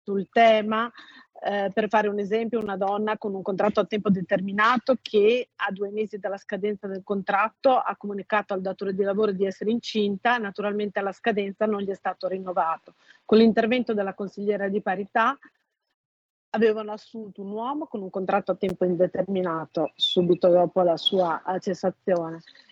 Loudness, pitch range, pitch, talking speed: -25 LUFS, 190-215 Hz, 205 Hz, 160 wpm